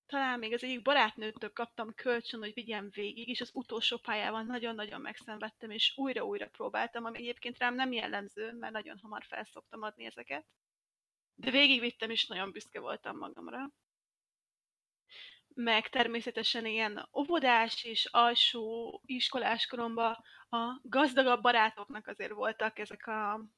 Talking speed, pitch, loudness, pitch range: 130 wpm, 235 Hz, -33 LUFS, 220-250 Hz